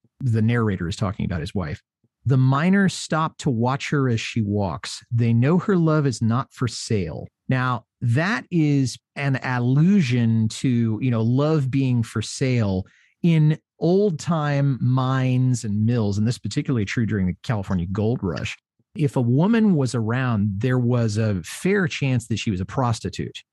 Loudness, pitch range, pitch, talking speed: -22 LUFS, 110-140 Hz, 125 Hz, 170 wpm